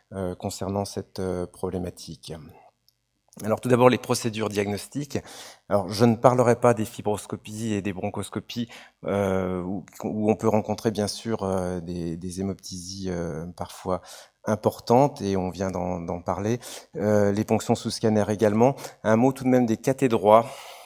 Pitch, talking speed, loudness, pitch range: 105 Hz, 160 wpm, -25 LUFS, 95-115 Hz